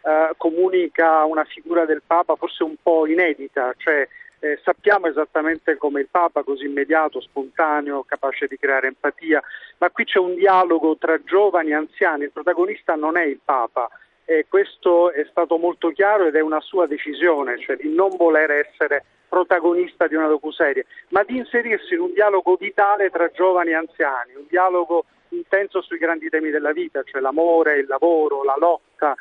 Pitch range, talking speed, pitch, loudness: 155-185 Hz, 175 wpm, 165 Hz, -19 LUFS